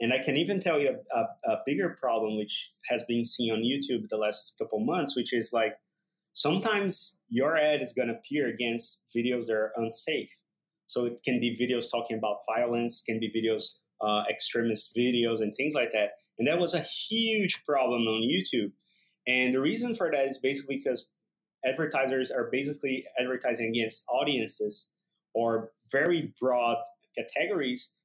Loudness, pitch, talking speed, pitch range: -29 LUFS, 125 Hz, 170 wpm, 115-150 Hz